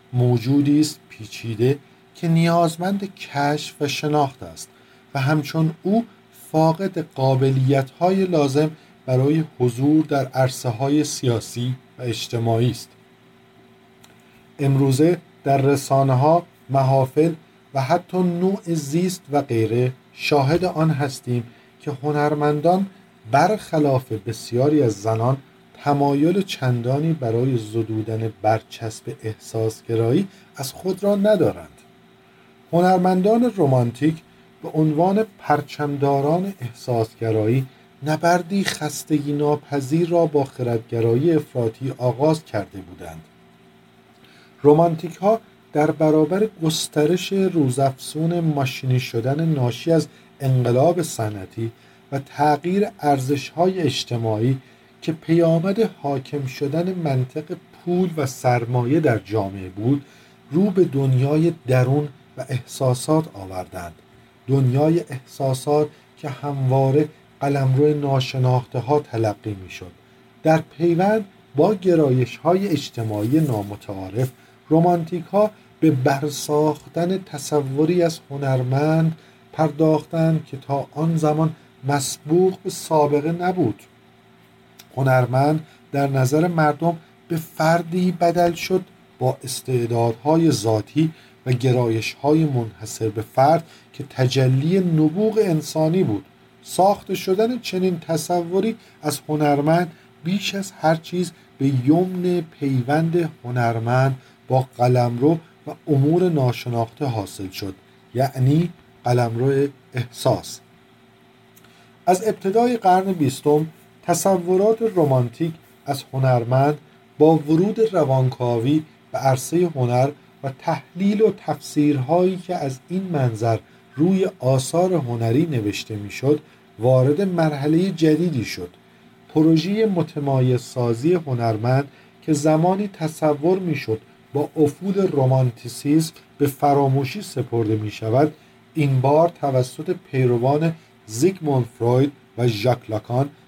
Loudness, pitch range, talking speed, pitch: -21 LUFS, 125-165 Hz, 100 wpm, 145 Hz